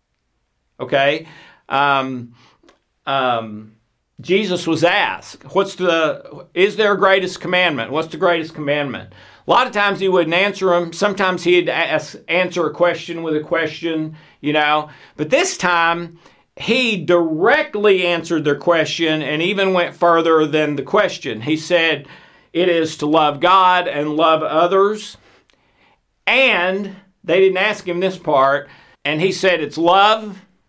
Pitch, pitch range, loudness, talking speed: 170 Hz, 150-185 Hz, -17 LUFS, 145 wpm